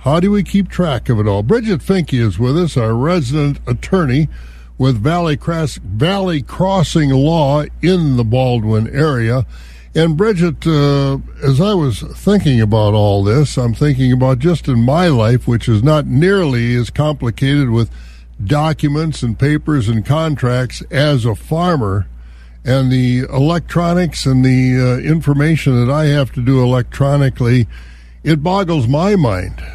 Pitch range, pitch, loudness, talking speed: 120-160 Hz, 135 Hz, -14 LUFS, 150 wpm